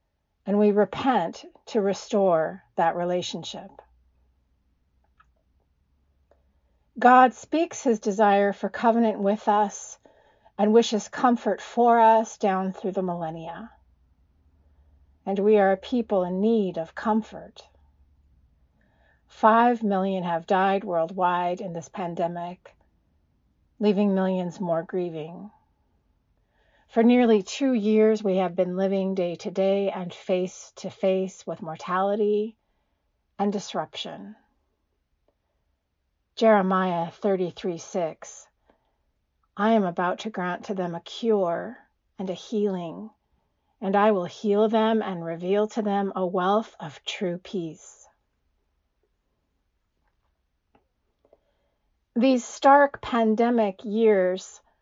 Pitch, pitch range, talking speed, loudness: 190 Hz, 160-215 Hz, 105 wpm, -24 LUFS